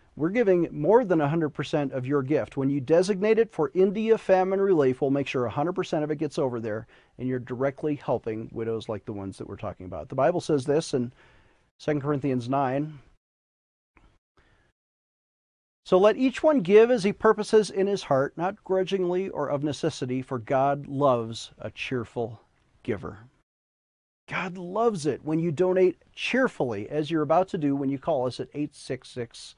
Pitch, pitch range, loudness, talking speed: 150 Hz, 130-185 Hz, -26 LUFS, 175 wpm